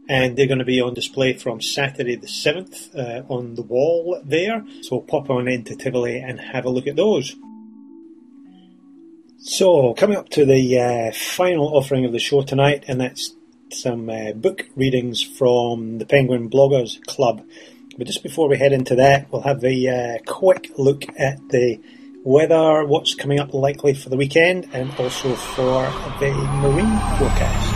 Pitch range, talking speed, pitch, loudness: 125-160 Hz, 175 wpm, 135 Hz, -19 LUFS